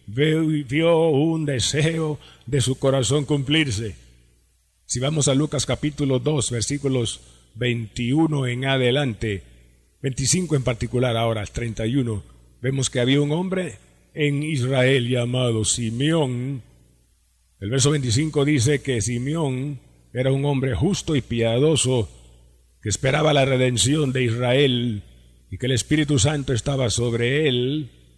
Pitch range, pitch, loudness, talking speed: 110-145 Hz, 130 Hz, -21 LUFS, 120 wpm